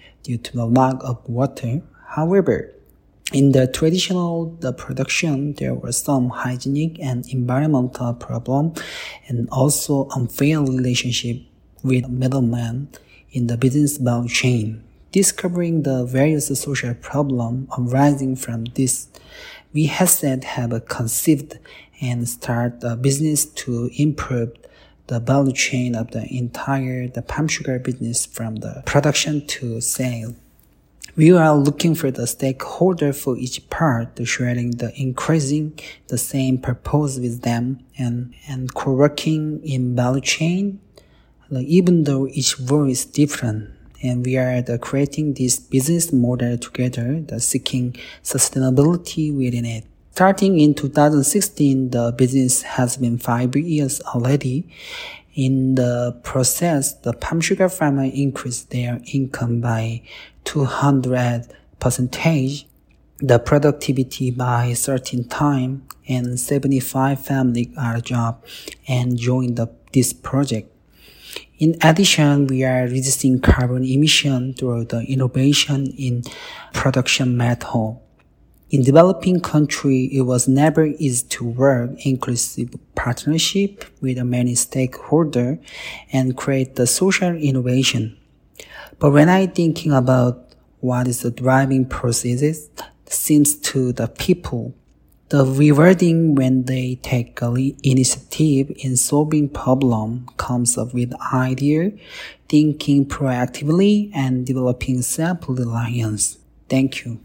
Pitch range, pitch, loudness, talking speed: 125-145 Hz, 130 Hz, -19 LUFS, 120 wpm